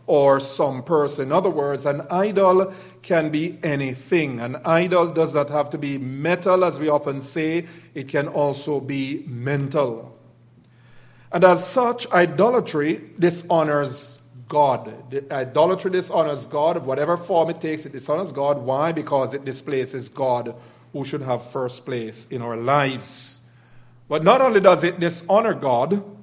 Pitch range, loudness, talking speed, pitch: 130-170 Hz, -21 LUFS, 150 wpm, 145 Hz